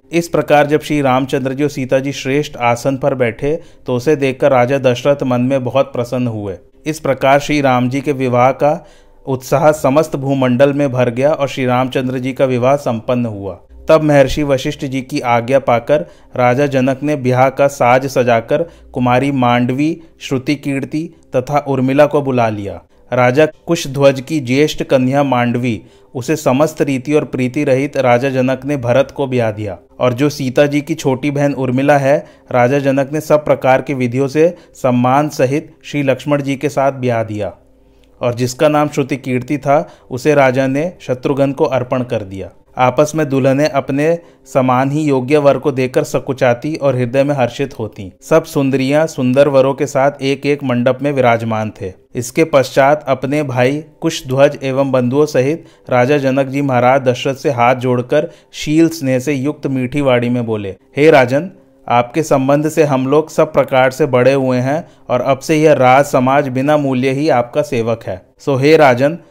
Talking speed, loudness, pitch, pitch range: 180 wpm, -14 LUFS, 135 Hz, 125-145 Hz